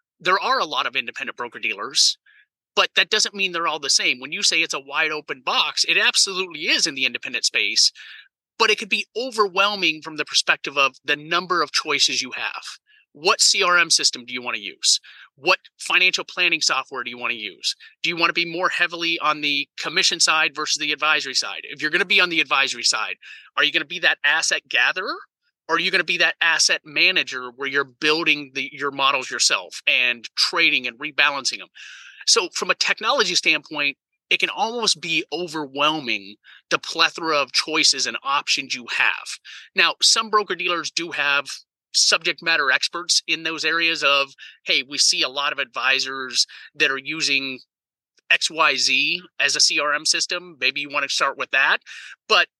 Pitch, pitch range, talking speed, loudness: 160 Hz, 140-180 Hz, 195 wpm, -19 LUFS